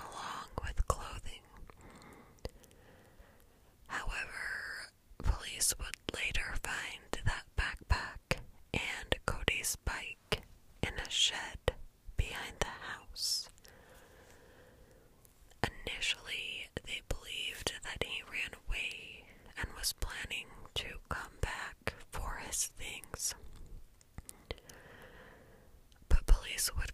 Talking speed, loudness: 85 wpm, -38 LUFS